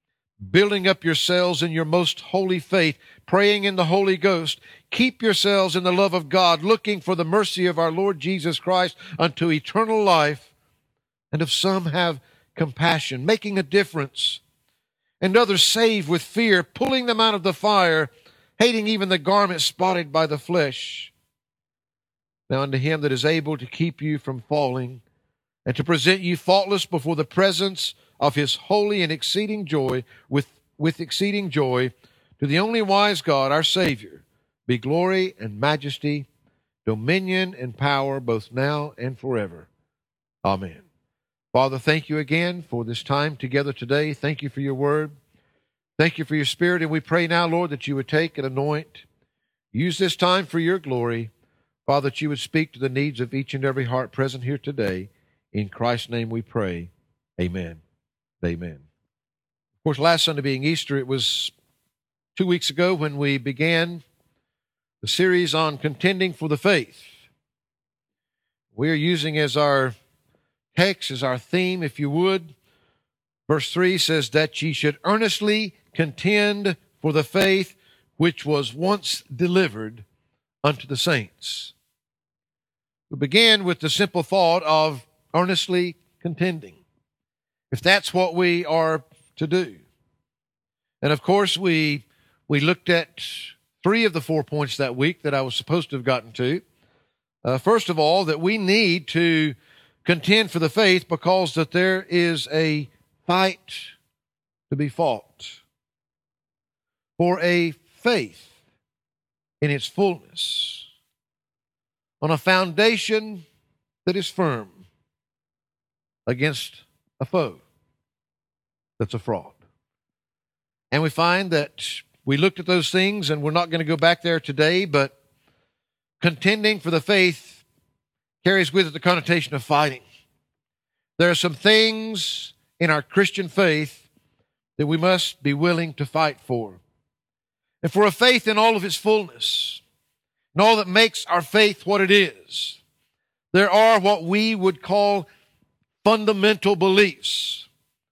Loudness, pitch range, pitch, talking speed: -21 LUFS, 140-185 Hz, 165 Hz, 150 wpm